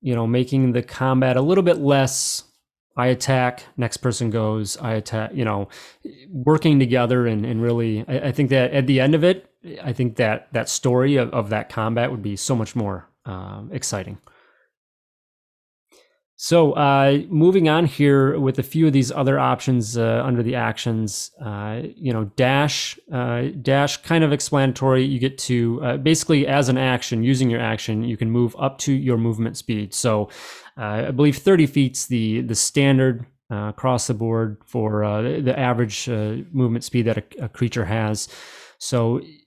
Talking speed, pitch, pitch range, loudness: 180 wpm, 125 Hz, 115-135 Hz, -20 LUFS